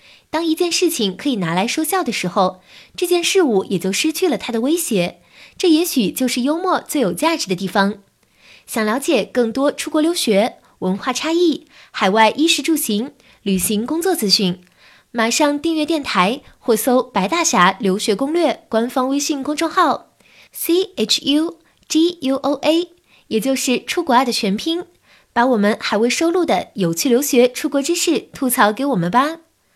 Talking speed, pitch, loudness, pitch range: 255 characters per minute, 265 Hz, -18 LUFS, 215-320 Hz